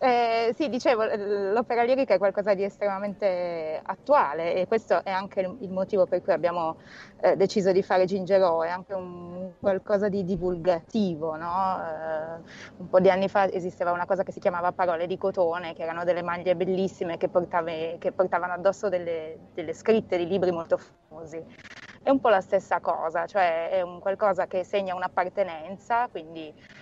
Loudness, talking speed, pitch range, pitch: -26 LUFS, 175 wpm, 175-200 Hz, 185 Hz